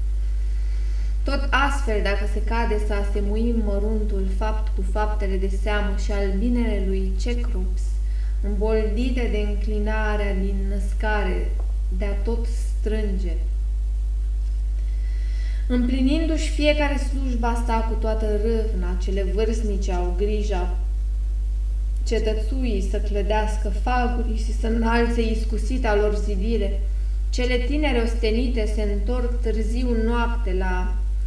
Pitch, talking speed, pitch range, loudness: 210 Hz, 105 wpm, 185-230 Hz, -24 LUFS